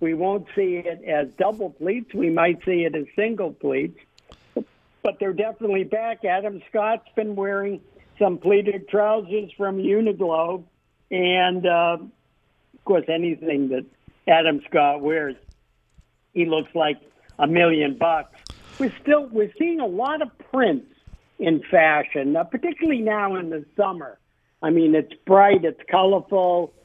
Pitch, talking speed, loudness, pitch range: 185 Hz, 145 wpm, -22 LUFS, 160-210 Hz